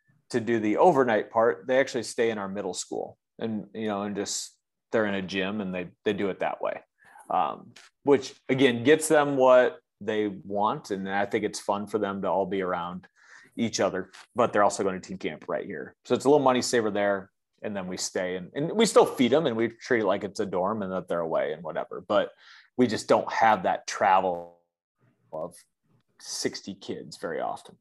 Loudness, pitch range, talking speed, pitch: -26 LUFS, 100-125 Hz, 220 wpm, 105 Hz